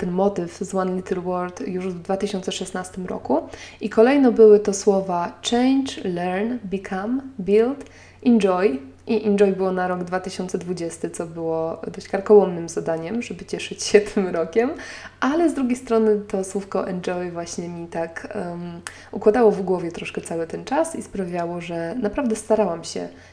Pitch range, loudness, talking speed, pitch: 180-215 Hz, -22 LUFS, 155 wpm, 195 Hz